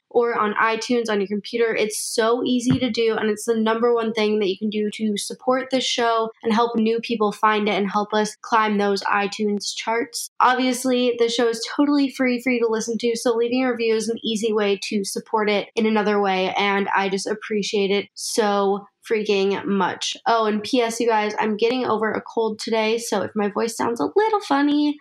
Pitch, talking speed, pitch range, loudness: 225 Hz, 215 wpm, 210-235 Hz, -21 LUFS